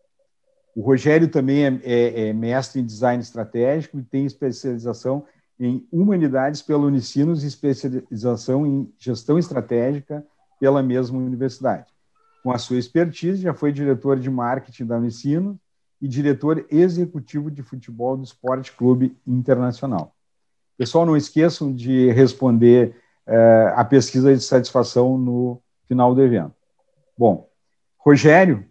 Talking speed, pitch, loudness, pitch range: 130 wpm, 130 Hz, -19 LUFS, 125-145 Hz